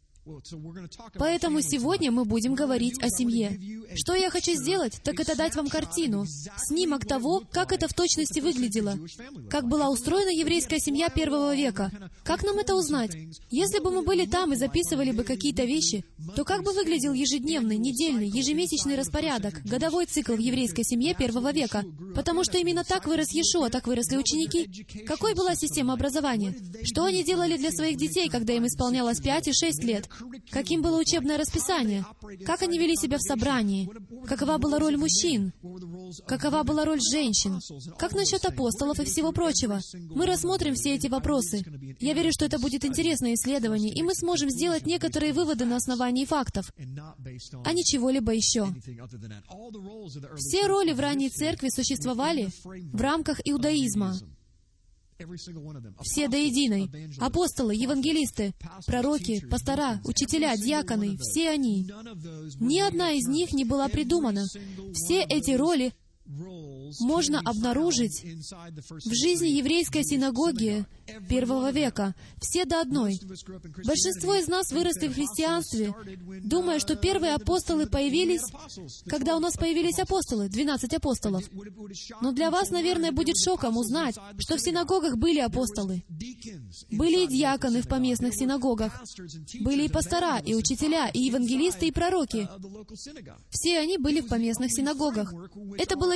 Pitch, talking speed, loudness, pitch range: 275 Hz, 145 wpm, -27 LUFS, 215-320 Hz